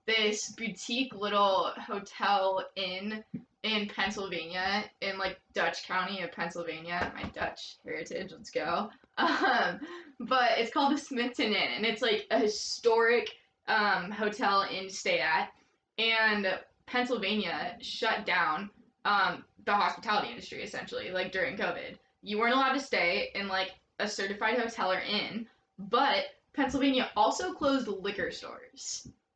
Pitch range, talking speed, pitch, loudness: 195-245 Hz, 135 wpm, 215 Hz, -30 LUFS